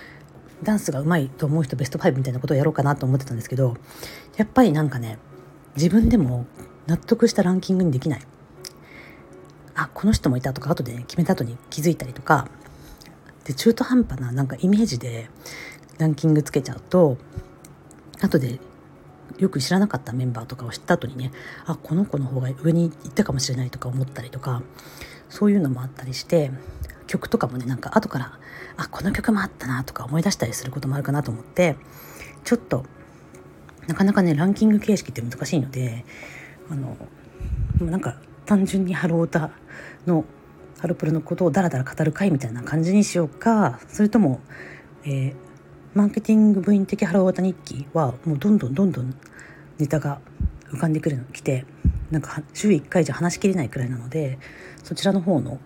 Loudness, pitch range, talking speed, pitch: -23 LUFS, 130-180 Hz, 370 characters per minute, 150 Hz